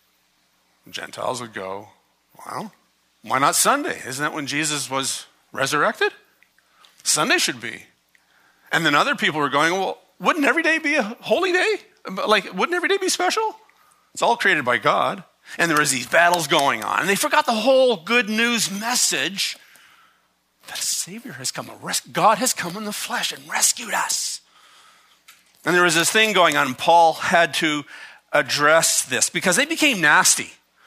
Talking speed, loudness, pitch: 170 wpm, -19 LUFS, 220 Hz